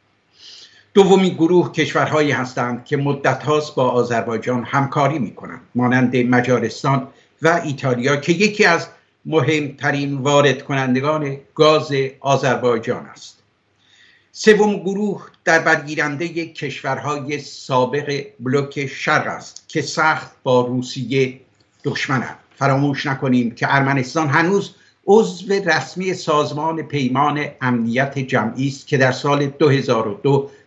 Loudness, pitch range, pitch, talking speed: -18 LUFS, 130-160 Hz, 140 Hz, 110 wpm